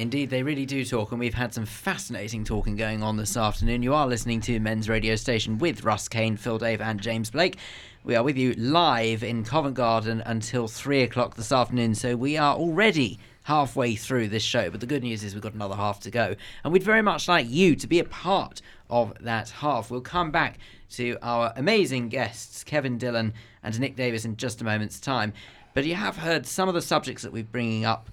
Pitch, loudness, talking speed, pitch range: 120 Hz, -26 LUFS, 220 wpm, 110-135 Hz